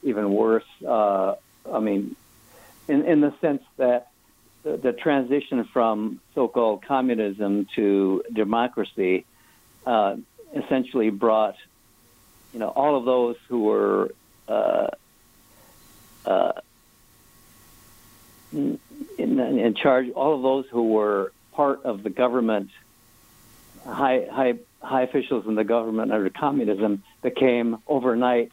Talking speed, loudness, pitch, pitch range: 110 wpm, -23 LUFS, 115 Hz, 110-130 Hz